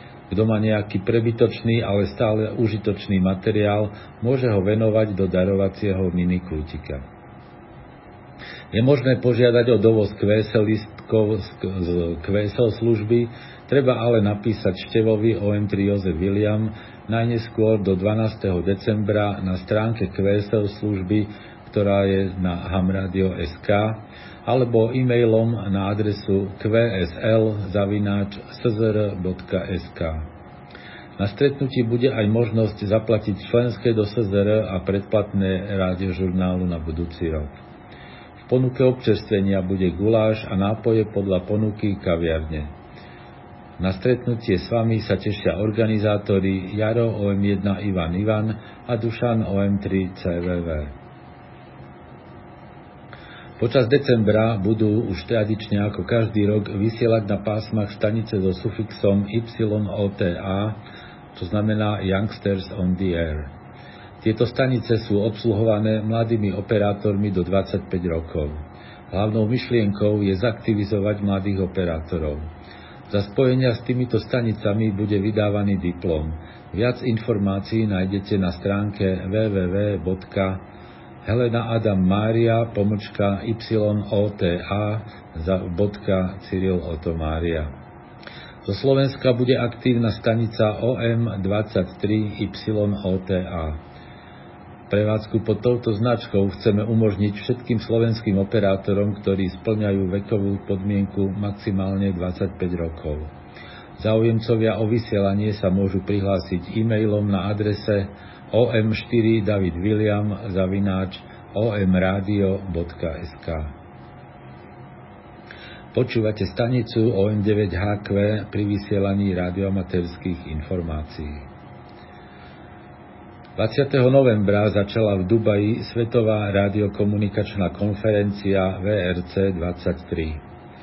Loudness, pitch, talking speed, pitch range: -22 LUFS, 105 Hz, 90 wpm, 95-110 Hz